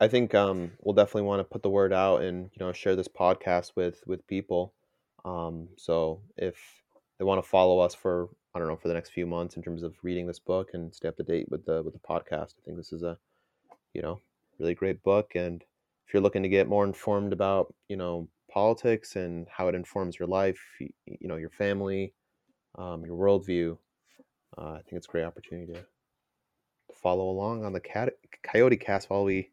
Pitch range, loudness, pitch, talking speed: 85-100 Hz, -29 LUFS, 95 Hz, 215 wpm